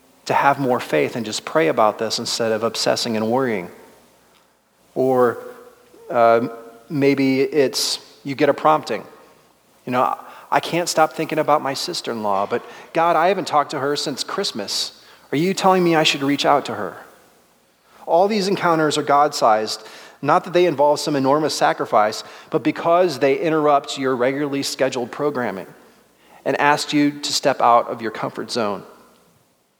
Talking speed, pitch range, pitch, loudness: 165 wpm, 125-155 Hz, 145 Hz, -19 LUFS